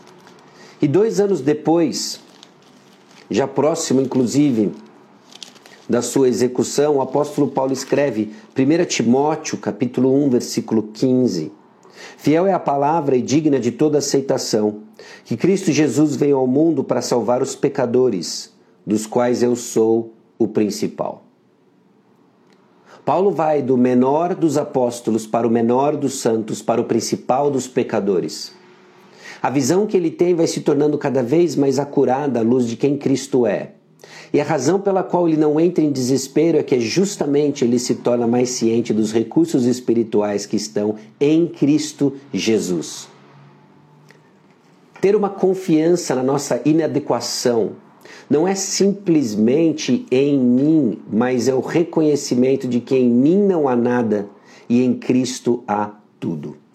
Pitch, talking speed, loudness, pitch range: 135 Hz, 140 wpm, -18 LUFS, 120-155 Hz